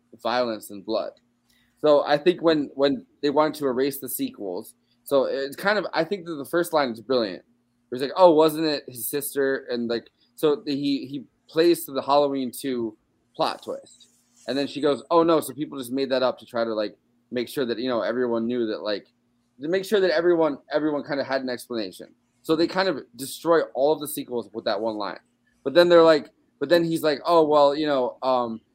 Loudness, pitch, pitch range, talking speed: -24 LUFS, 135 Hz, 120-155 Hz, 230 wpm